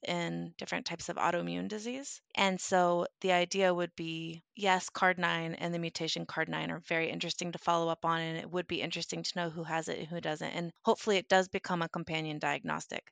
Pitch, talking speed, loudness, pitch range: 170 Hz, 210 wpm, -33 LUFS, 165-185 Hz